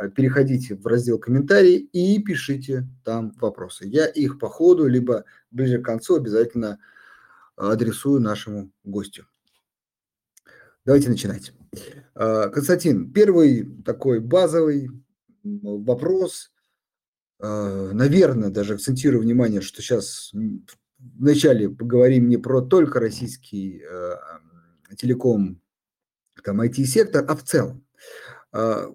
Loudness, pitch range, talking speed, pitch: -20 LUFS, 105-145 Hz, 90 wpm, 125 Hz